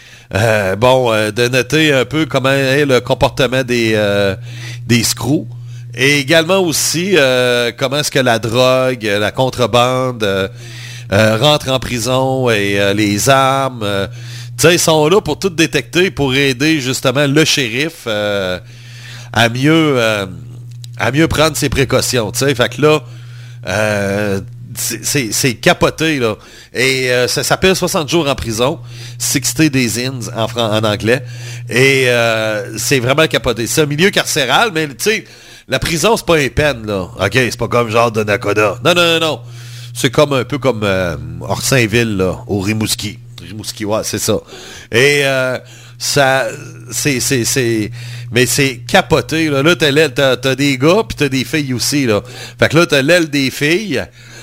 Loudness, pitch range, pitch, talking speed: -13 LUFS, 115-145 Hz, 125 Hz, 175 wpm